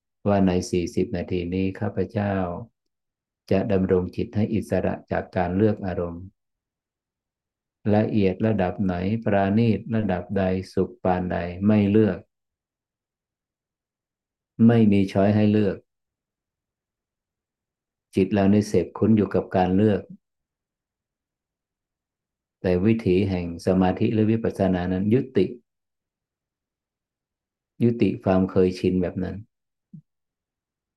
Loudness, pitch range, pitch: -23 LUFS, 90-105 Hz, 95 Hz